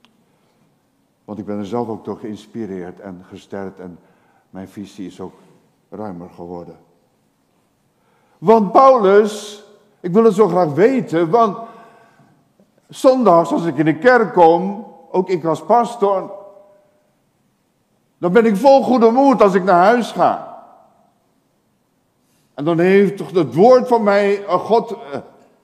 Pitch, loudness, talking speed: 195 Hz, -14 LUFS, 135 wpm